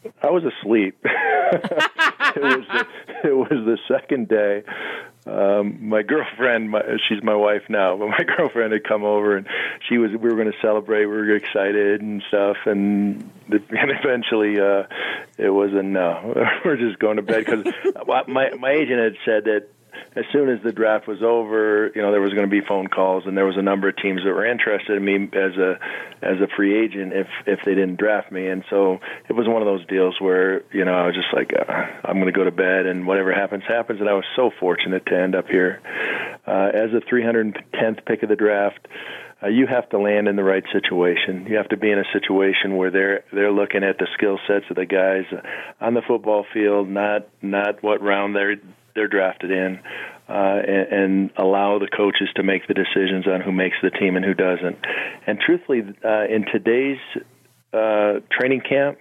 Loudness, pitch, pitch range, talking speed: -20 LUFS, 100 Hz, 95-110 Hz, 210 wpm